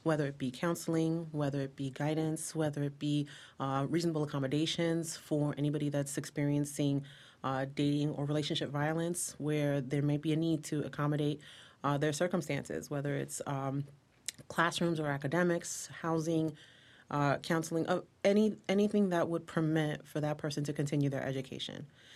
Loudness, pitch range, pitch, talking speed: -34 LUFS, 140-160 Hz, 150 Hz, 150 wpm